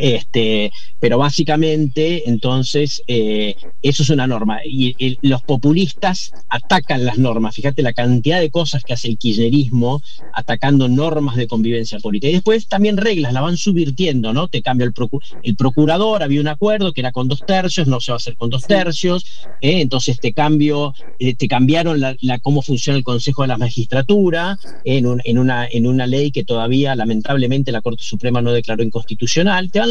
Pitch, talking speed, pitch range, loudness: 135 Hz, 190 wpm, 120-155 Hz, -17 LUFS